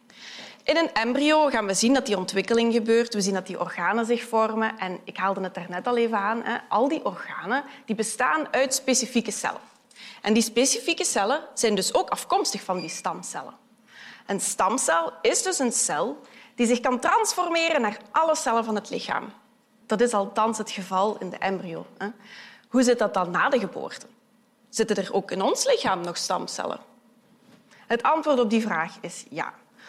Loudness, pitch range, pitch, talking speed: -24 LUFS, 210-260 Hz, 230 Hz, 185 wpm